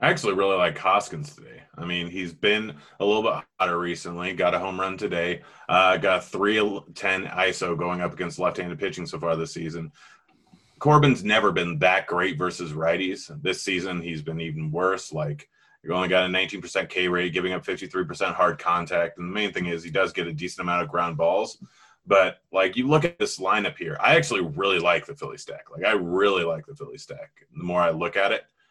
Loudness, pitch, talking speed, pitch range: -24 LUFS, 90 Hz, 215 wpm, 85-95 Hz